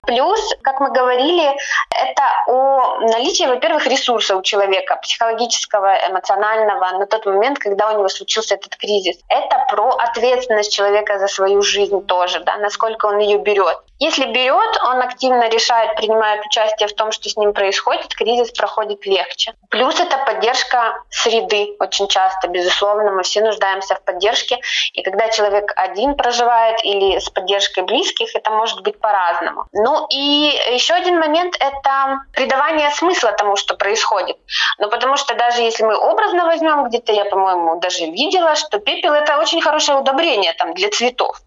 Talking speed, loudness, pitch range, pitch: 160 wpm, -16 LUFS, 200-270 Hz, 220 Hz